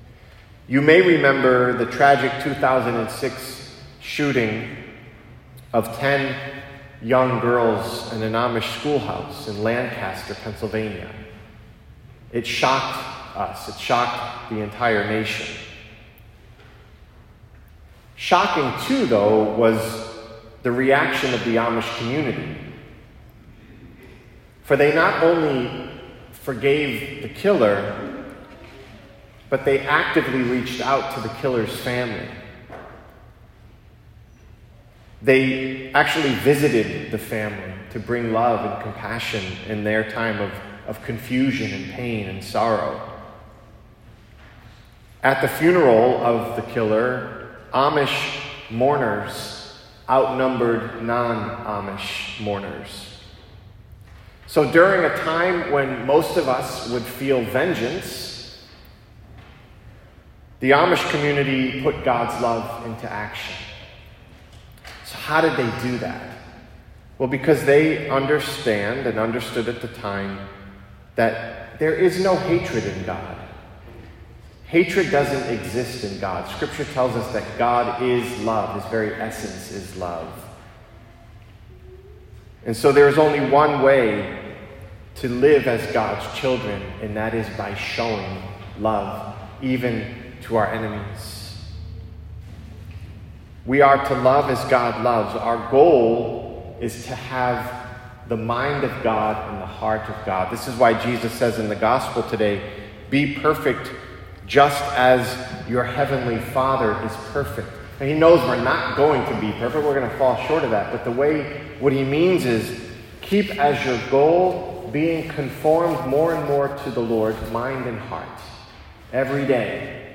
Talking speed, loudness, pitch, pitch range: 120 wpm, -21 LUFS, 115 Hz, 110-135 Hz